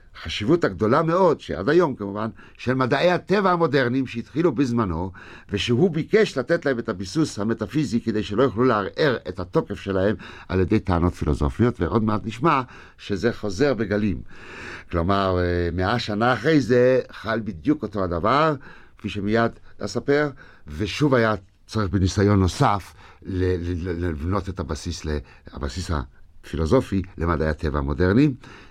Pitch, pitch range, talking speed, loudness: 105 Hz, 90-130 Hz, 125 wpm, -23 LUFS